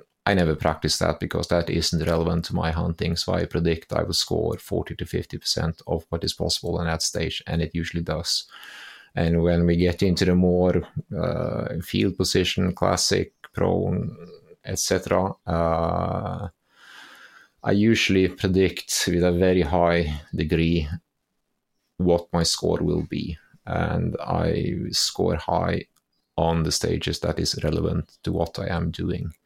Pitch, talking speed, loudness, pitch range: 85 Hz, 150 wpm, -24 LUFS, 80-90 Hz